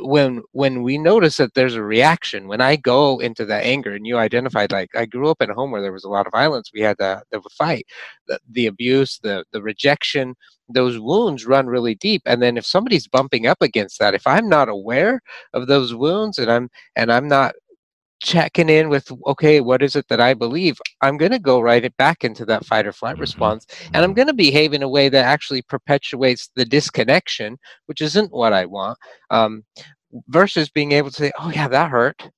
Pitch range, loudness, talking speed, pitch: 120-150 Hz, -18 LUFS, 220 wpm, 130 Hz